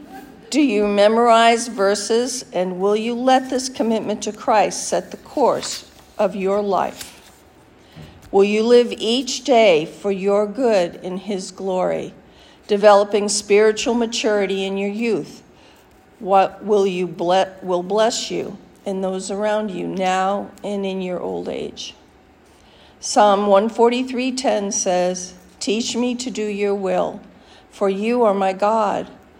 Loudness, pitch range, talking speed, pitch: -19 LUFS, 190-230 Hz, 135 wpm, 205 Hz